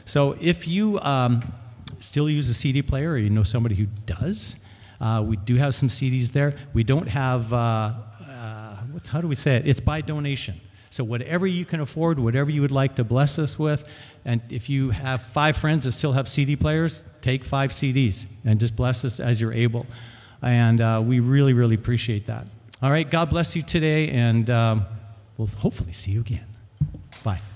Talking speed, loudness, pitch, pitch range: 195 wpm, -23 LUFS, 125 Hz, 110-145 Hz